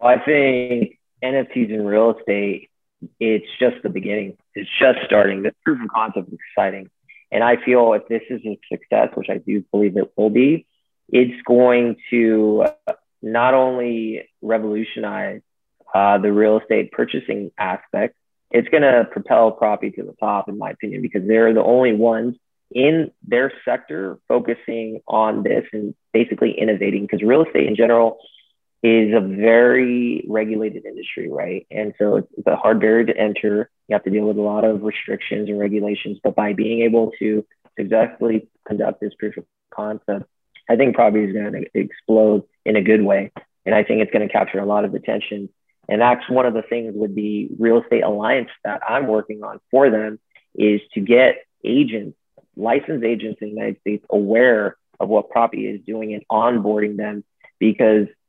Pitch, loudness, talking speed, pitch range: 110 Hz, -18 LUFS, 175 wpm, 105-115 Hz